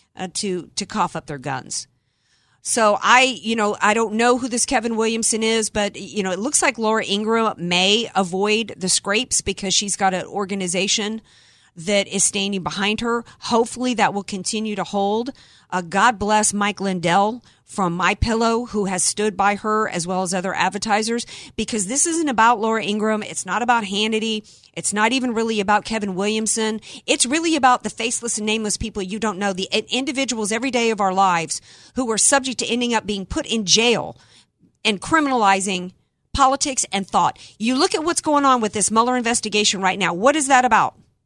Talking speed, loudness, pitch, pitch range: 190 wpm, -19 LUFS, 215 Hz, 195-235 Hz